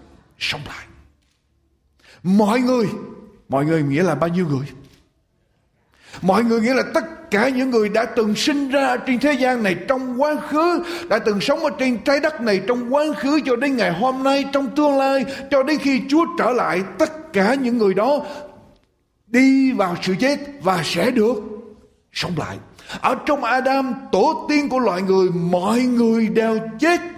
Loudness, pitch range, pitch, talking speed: -19 LUFS, 200-280 Hz, 250 Hz, 180 wpm